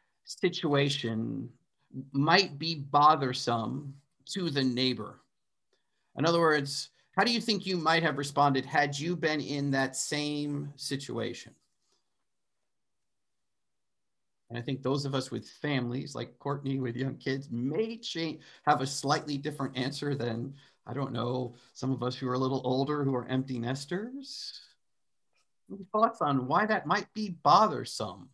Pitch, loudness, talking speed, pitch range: 140 Hz, -30 LUFS, 145 wpm, 130-155 Hz